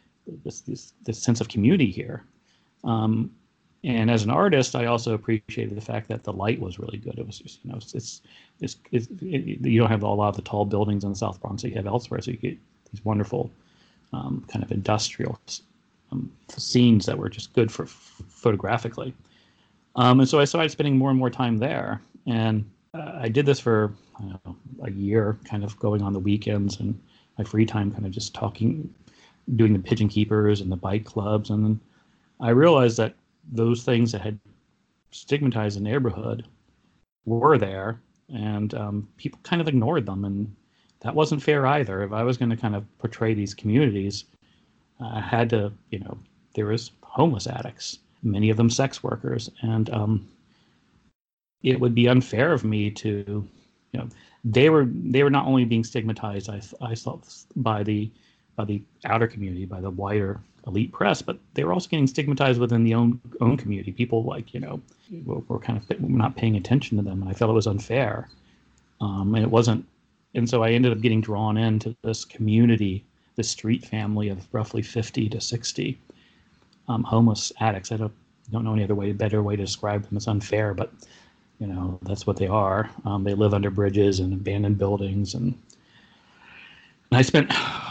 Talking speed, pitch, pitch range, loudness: 195 wpm, 110 Hz, 105-120 Hz, -24 LUFS